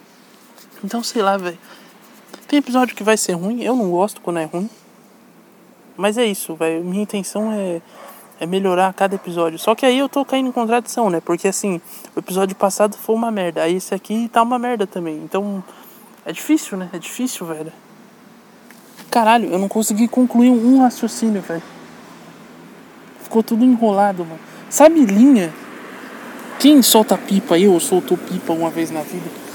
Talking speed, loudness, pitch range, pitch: 170 wpm, -17 LUFS, 185-240 Hz, 215 Hz